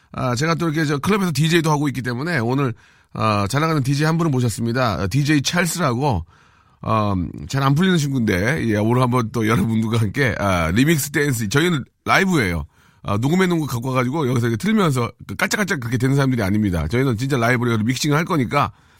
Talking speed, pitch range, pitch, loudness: 435 characters per minute, 115-155 Hz, 130 Hz, -19 LUFS